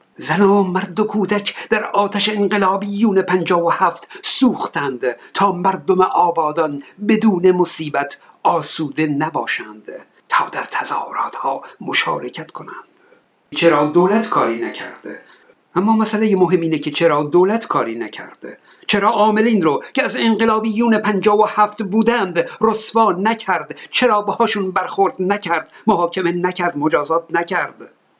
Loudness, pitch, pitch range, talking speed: -17 LUFS, 195 Hz, 170-215 Hz, 125 wpm